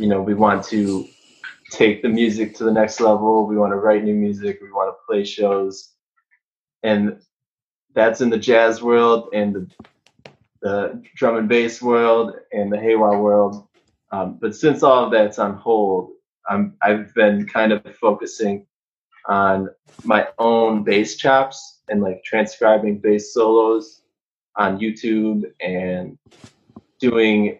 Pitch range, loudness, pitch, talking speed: 105-115 Hz, -18 LUFS, 110 Hz, 150 wpm